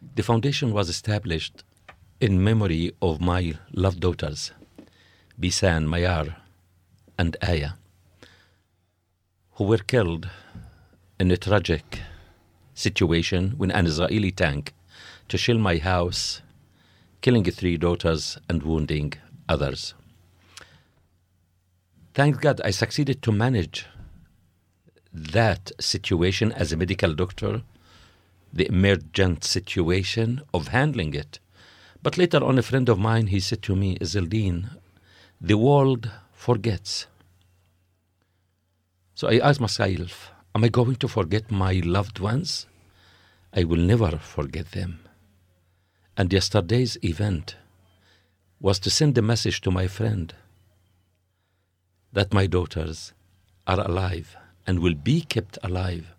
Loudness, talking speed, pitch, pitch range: -24 LUFS, 115 wpm, 95 Hz, 90-105 Hz